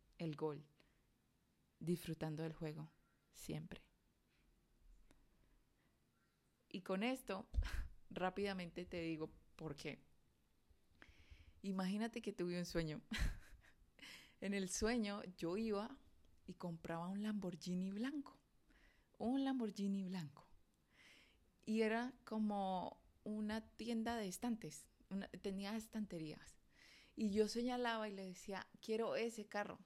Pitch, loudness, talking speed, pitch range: 195 Hz, -45 LUFS, 100 wpm, 175-220 Hz